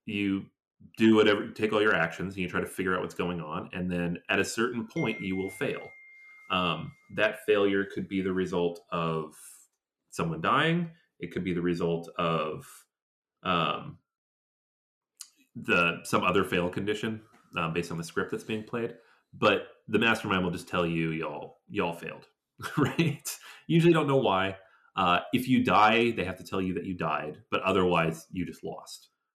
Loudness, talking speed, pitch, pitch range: -28 LUFS, 180 wpm, 95 Hz, 85-115 Hz